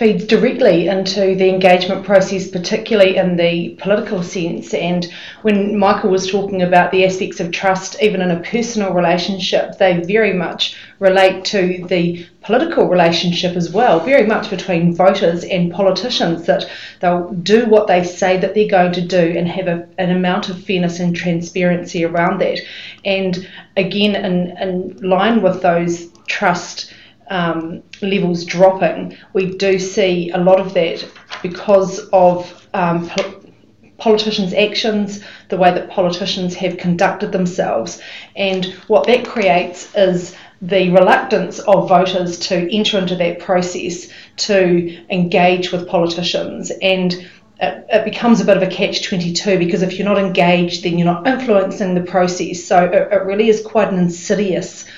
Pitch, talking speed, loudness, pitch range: 185 Hz, 155 wpm, -15 LUFS, 180-195 Hz